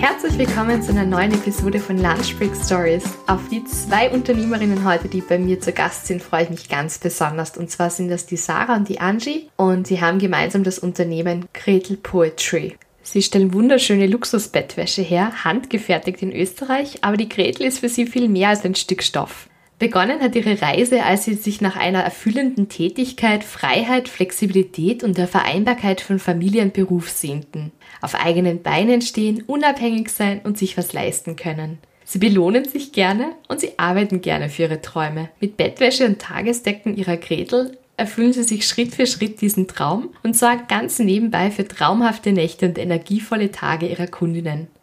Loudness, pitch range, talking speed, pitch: -19 LUFS, 175-225 Hz, 175 wpm, 195 Hz